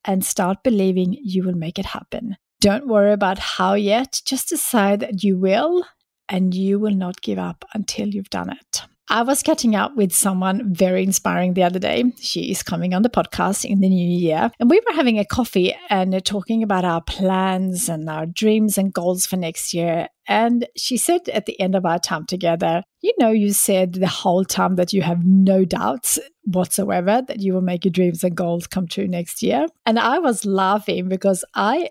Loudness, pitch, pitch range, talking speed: -19 LUFS, 195 Hz, 185-215 Hz, 205 wpm